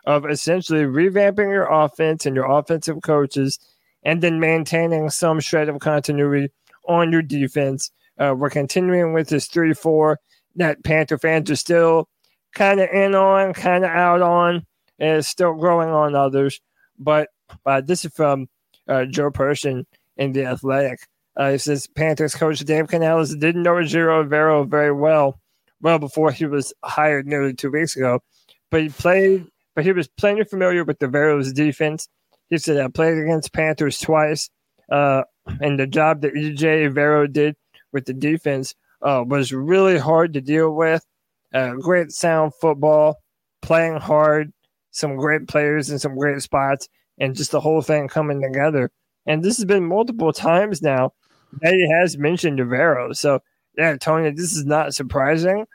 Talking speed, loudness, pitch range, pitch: 165 wpm, -19 LUFS, 145-165 Hz, 155 Hz